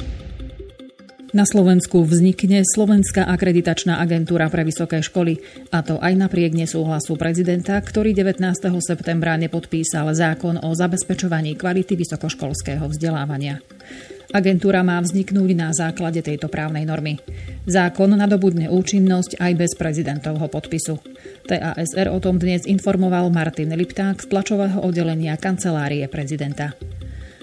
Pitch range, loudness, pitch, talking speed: 160-185 Hz, -19 LUFS, 170 Hz, 115 wpm